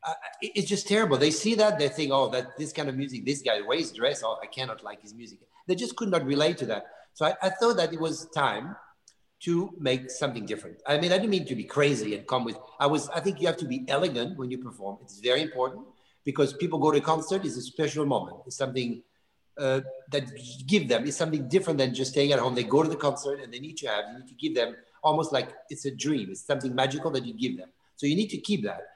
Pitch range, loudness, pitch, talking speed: 130-160 Hz, -28 LUFS, 145 Hz, 265 wpm